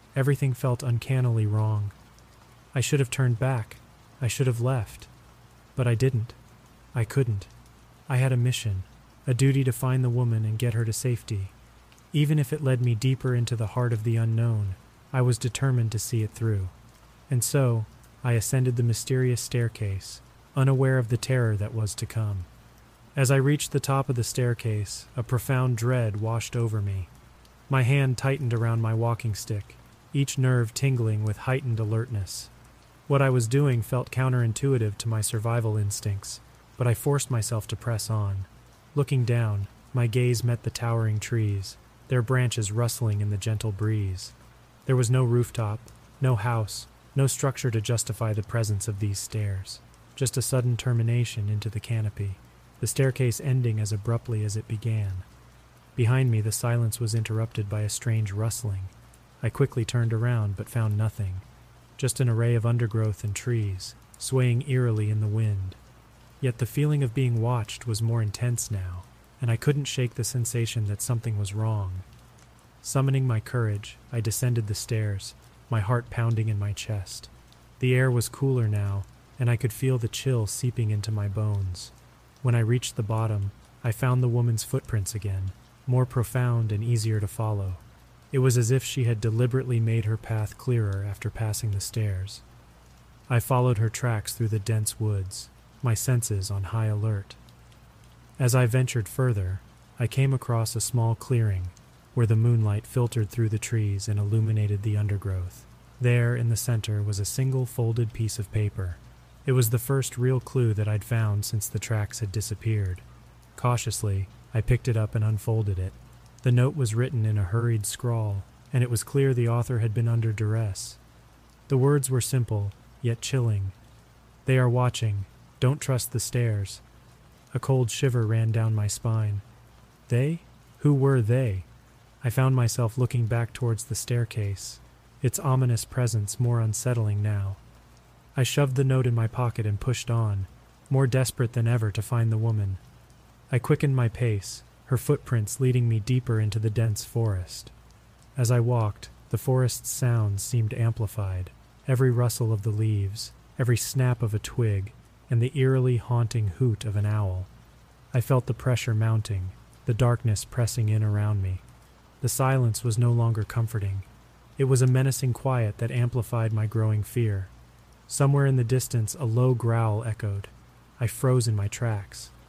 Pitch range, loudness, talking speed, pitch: 110-125 Hz, -26 LUFS, 170 wpm, 115 Hz